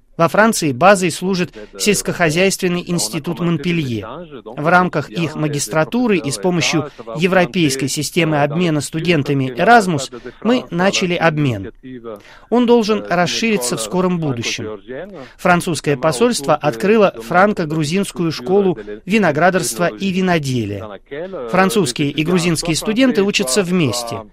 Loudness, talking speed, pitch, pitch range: -16 LUFS, 105 wpm, 170 Hz, 145-190 Hz